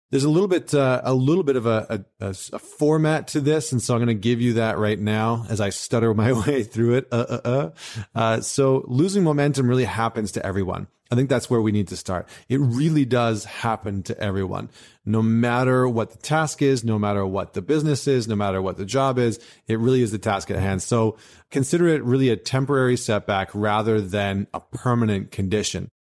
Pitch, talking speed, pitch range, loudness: 115 Hz, 215 wpm, 105-130 Hz, -22 LUFS